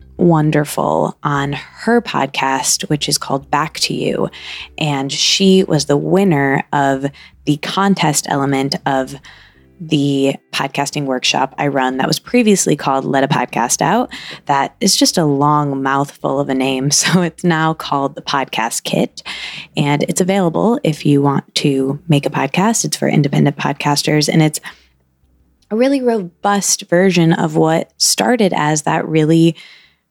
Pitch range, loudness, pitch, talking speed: 140-175 Hz, -15 LUFS, 150 Hz, 150 wpm